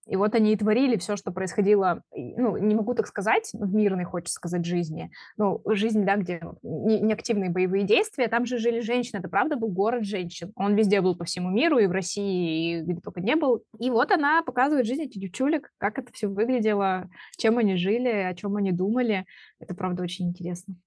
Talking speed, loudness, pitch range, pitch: 205 wpm, -25 LUFS, 185-230 Hz, 205 Hz